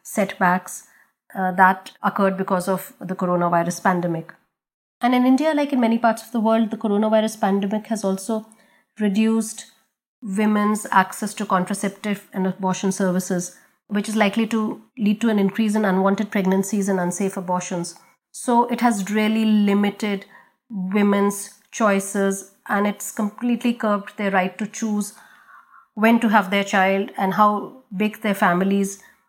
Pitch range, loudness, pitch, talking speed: 195-220 Hz, -21 LUFS, 205 Hz, 145 wpm